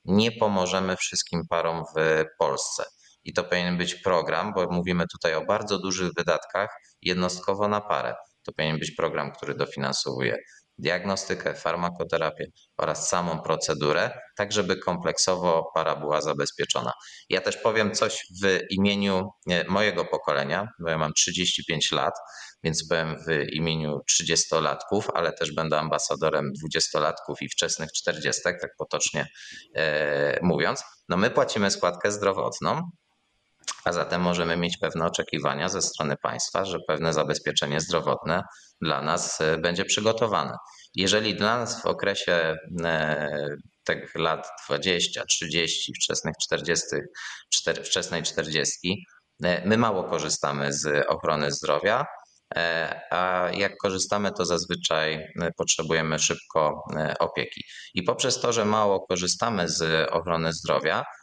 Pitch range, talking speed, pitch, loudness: 80-95 Hz, 125 wpm, 85 Hz, -26 LUFS